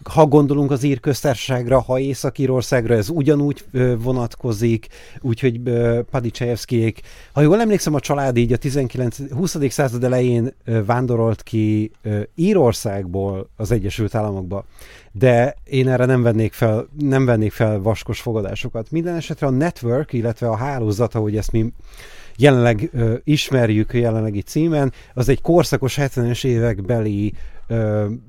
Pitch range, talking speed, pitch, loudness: 115-140 Hz, 120 wpm, 120 Hz, -19 LUFS